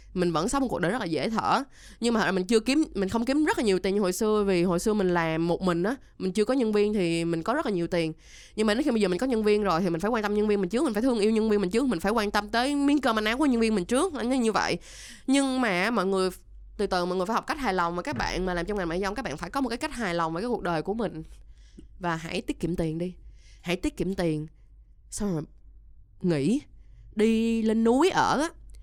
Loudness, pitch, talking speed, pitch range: -26 LUFS, 205 Hz, 300 wpm, 175-235 Hz